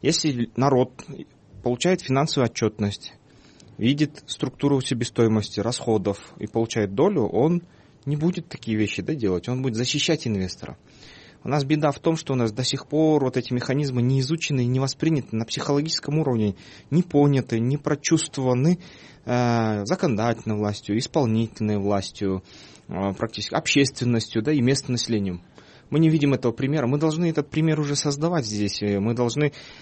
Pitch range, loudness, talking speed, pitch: 110-150 Hz, -23 LUFS, 150 wpm, 130 Hz